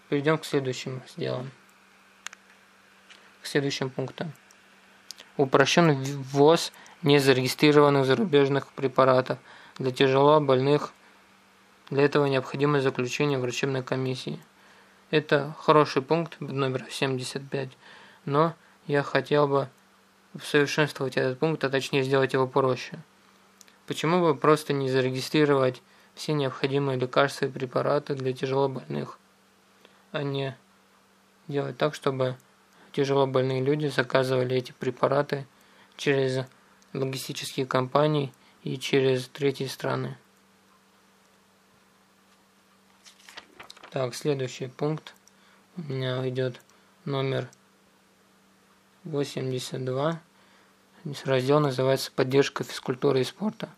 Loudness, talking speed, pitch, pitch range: -26 LUFS, 90 wpm, 140 Hz, 130-145 Hz